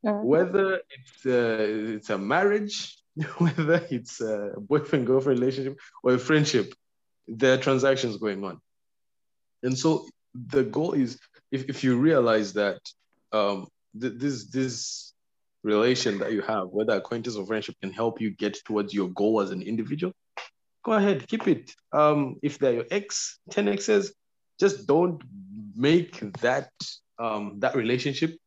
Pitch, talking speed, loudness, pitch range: 130 Hz, 150 wpm, -26 LUFS, 110-160 Hz